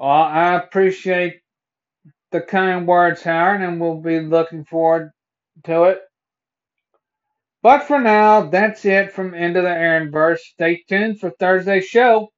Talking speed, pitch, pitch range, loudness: 145 wpm, 180 Hz, 165-195 Hz, -16 LUFS